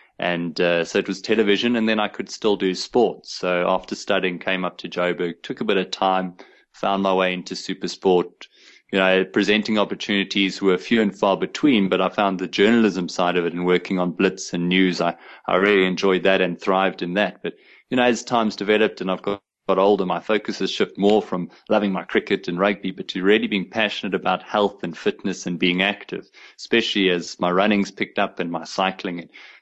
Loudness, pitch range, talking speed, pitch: -21 LUFS, 90-100 Hz, 215 wpm, 95 Hz